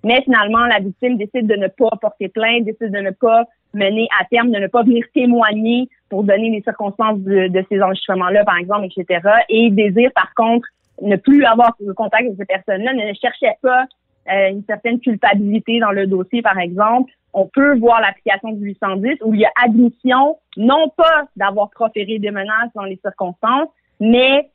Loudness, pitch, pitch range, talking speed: -15 LUFS, 220 Hz, 200-240 Hz, 190 wpm